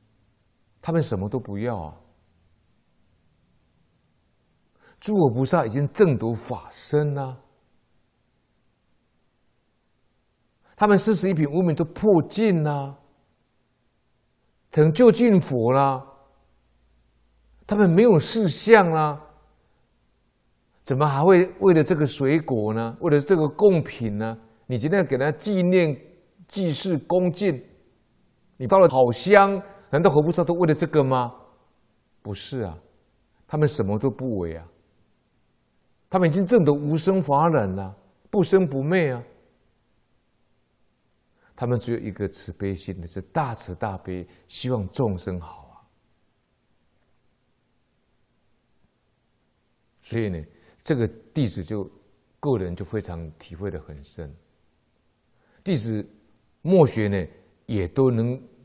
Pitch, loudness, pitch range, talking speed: 130 Hz, -22 LUFS, 100-165 Hz, 170 characters per minute